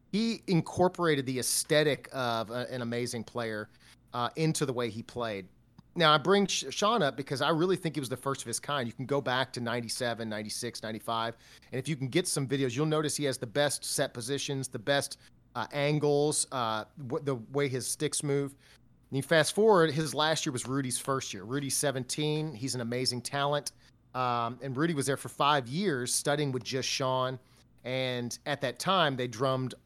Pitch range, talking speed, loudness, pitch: 120-150 Hz, 200 wpm, -30 LUFS, 135 Hz